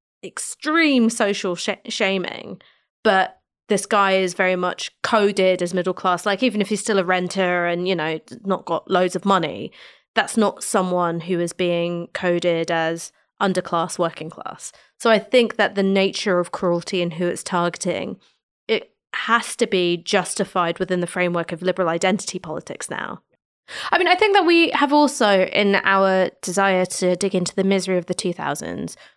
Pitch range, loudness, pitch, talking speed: 175-205 Hz, -20 LUFS, 185 Hz, 175 wpm